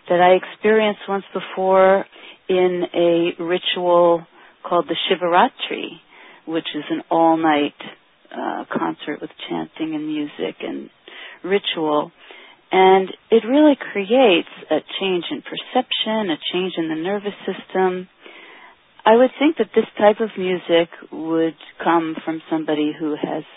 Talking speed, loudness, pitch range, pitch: 130 wpm, -19 LUFS, 170-220 Hz, 185 Hz